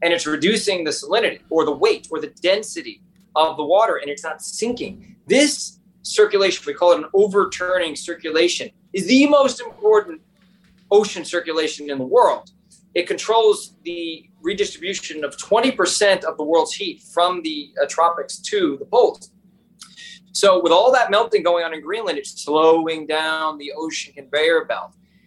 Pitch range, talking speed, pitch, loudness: 165-220 Hz, 160 wpm, 190 Hz, -19 LUFS